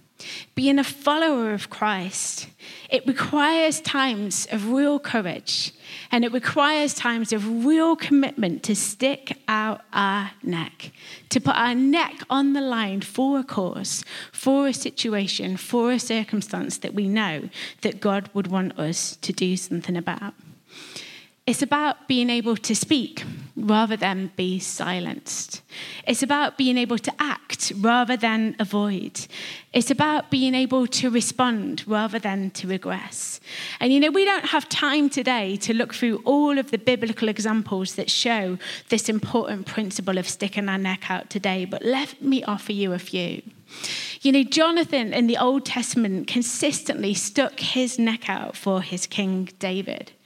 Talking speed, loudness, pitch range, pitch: 155 wpm, -23 LUFS, 200-270 Hz, 230 Hz